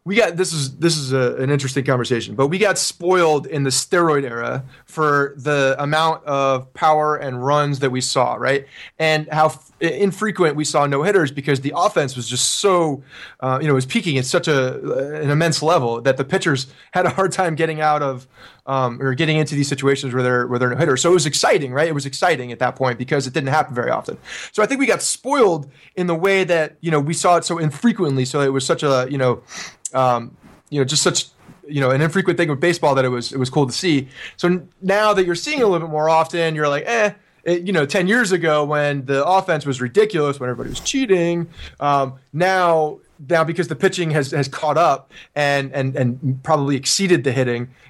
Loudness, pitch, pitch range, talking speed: -18 LUFS, 145 Hz, 135-170 Hz, 230 wpm